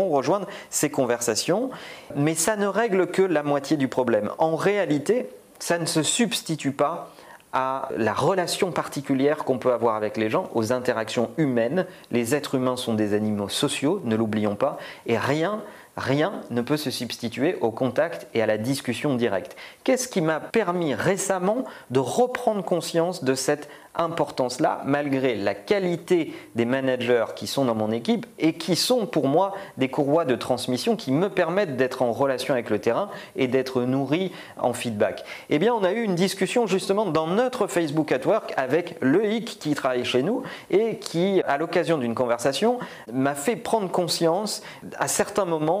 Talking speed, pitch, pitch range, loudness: 175 wpm, 150 Hz, 125-190 Hz, -24 LUFS